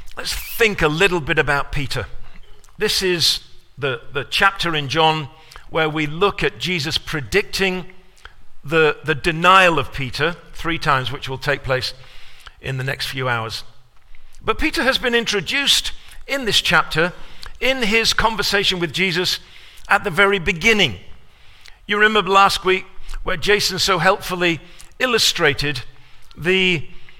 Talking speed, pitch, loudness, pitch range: 140 wpm, 175 Hz, -18 LUFS, 145-200 Hz